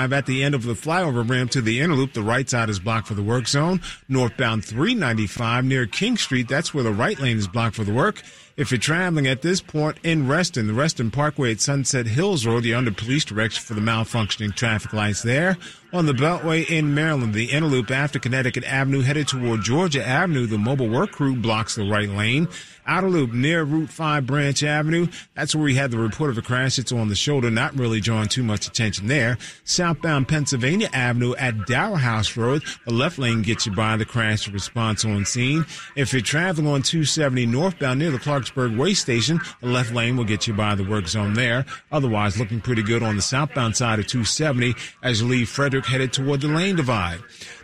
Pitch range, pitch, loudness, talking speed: 115-150 Hz, 125 Hz, -21 LUFS, 210 wpm